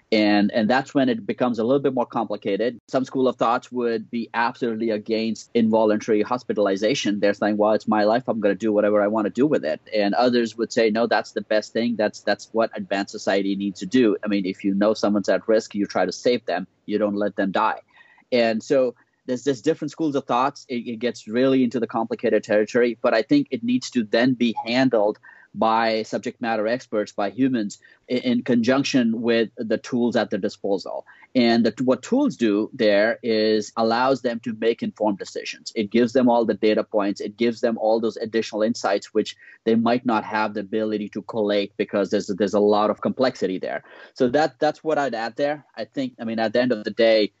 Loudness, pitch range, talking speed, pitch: -22 LUFS, 105-125 Hz, 220 wpm, 115 Hz